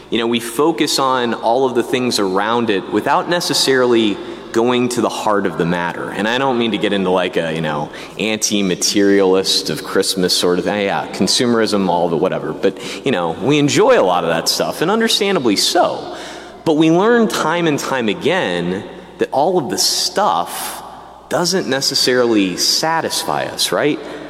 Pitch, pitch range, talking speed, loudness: 115 Hz, 95-145 Hz, 180 wpm, -16 LUFS